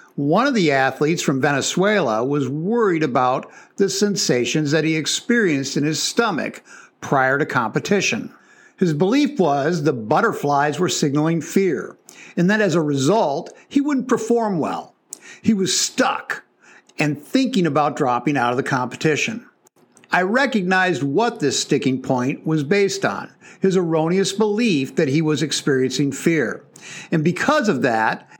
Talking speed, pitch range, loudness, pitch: 145 wpm, 145-205 Hz, -19 LUFS, 165 Hz